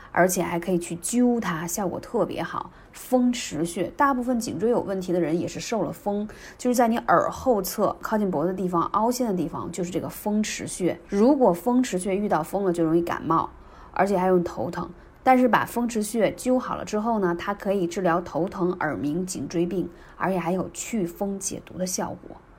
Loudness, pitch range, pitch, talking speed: -25 LUFS, 175-230 Hz, 190 Hz, 300 characters per minute